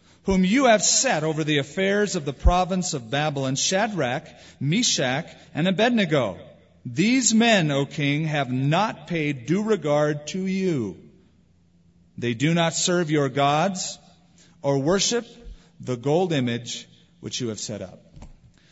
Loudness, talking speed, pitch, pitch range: -23 LUFS, 140 wpm, 155 Hz, 140-190 Hz